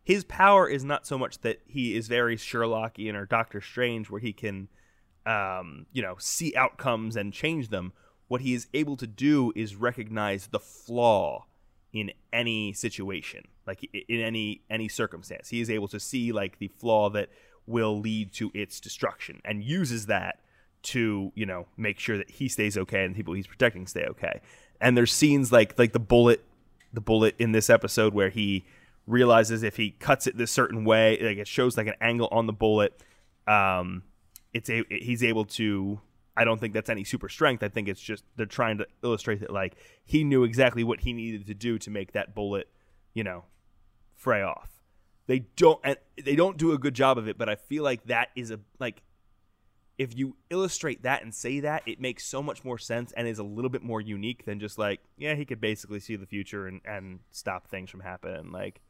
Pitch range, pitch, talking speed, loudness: 100-120 Hz, 110 Hz, 205 wpm, -27 LUFS